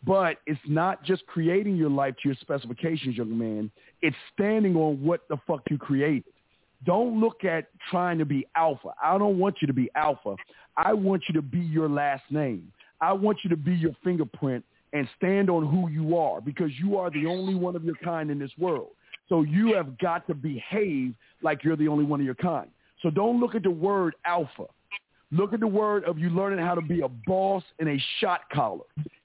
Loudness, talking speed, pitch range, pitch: -27 LUFS, 215 wpm, 145-190 Hz, 165 Hz